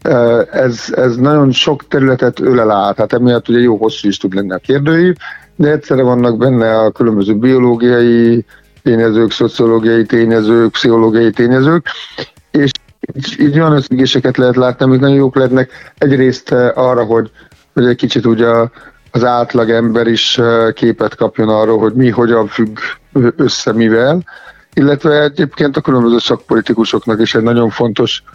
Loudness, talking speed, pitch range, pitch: -11 LUFS, 145 wpm, 115-130 Hz, 120 Hz